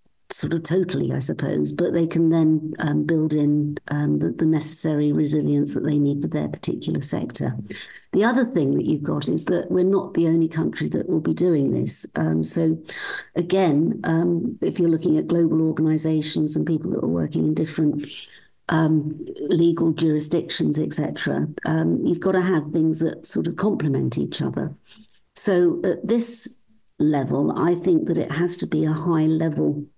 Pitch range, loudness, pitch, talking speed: 150-170 Hz, -22 LUFS, 160 Hz, 180 wpm